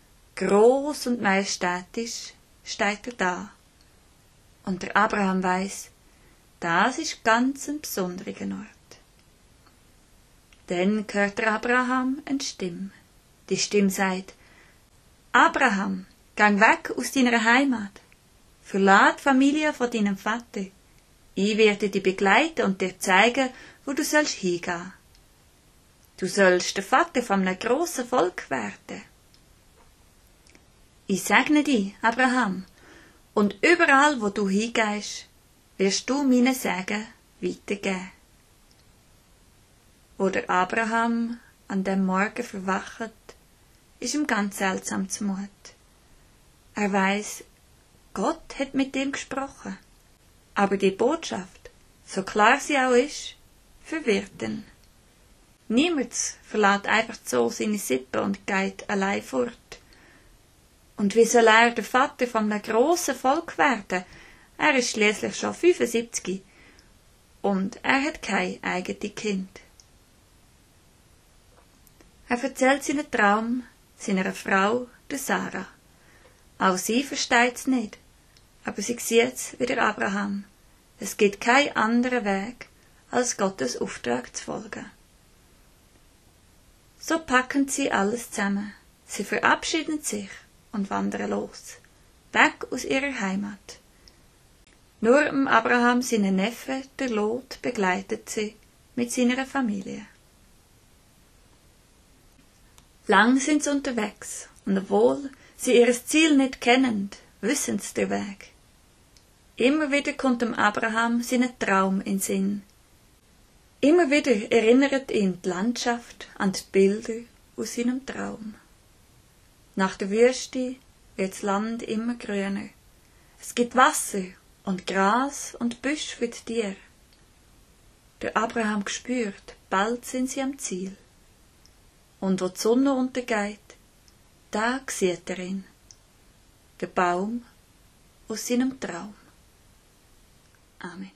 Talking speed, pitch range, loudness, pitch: 110 wpm, 195-255 Hz, -24 LUFS, 220 Hz